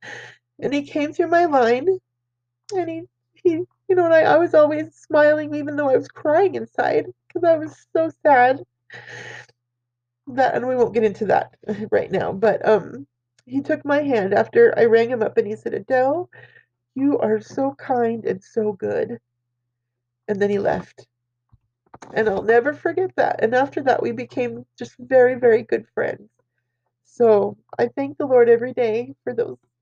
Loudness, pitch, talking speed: -20 LUFS, 245 Hz, 175 wpm